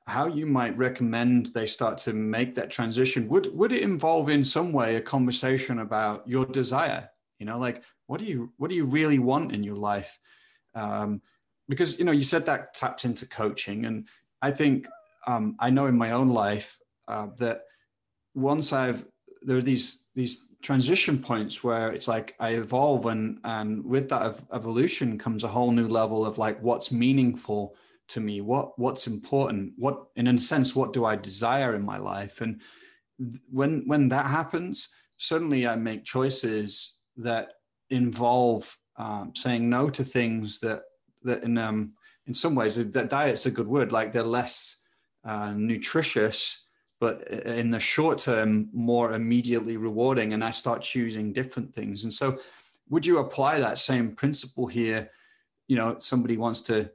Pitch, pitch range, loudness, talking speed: 120 Hz, 115-135 Hz, -27 LUFS, 175 wpm